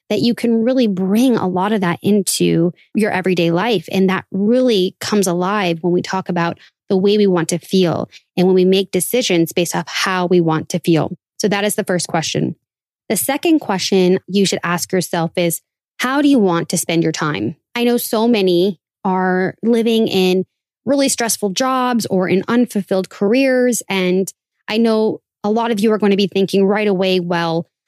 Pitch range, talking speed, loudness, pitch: 175-220 Hz, 195 wpm, -16 LUFS, 190 Hz